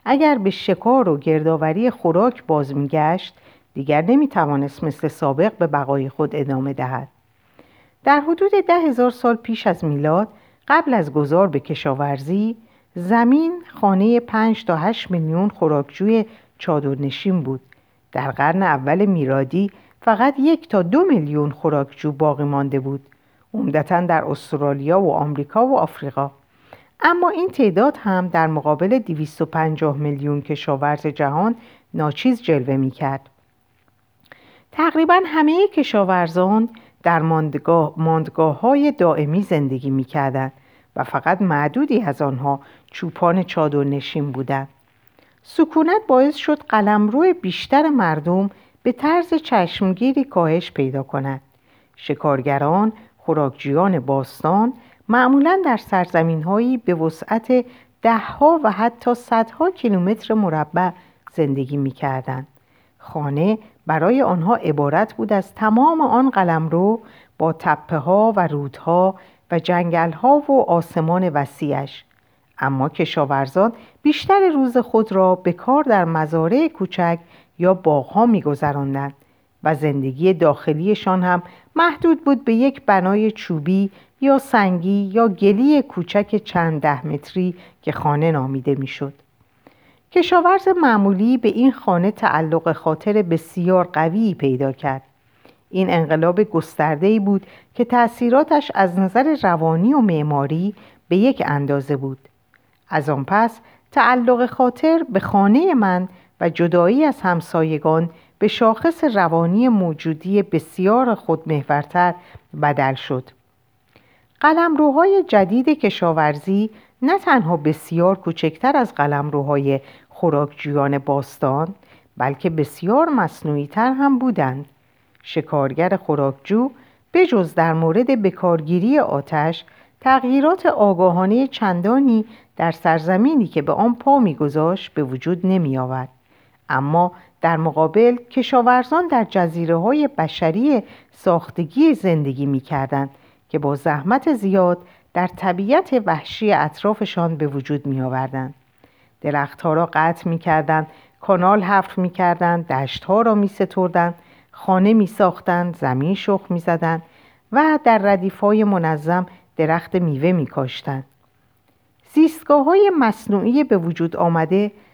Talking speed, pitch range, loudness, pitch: 115 wpm, 145-225 Hz, -18 LUFS, 175 Hz